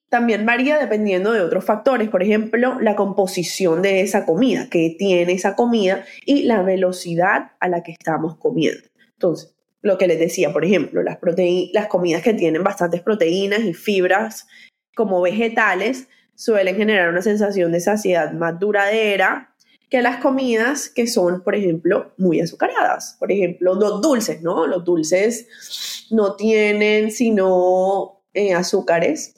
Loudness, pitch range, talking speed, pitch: -18 LUFS, 180-220 Hz, 150 wpm, 195 Hz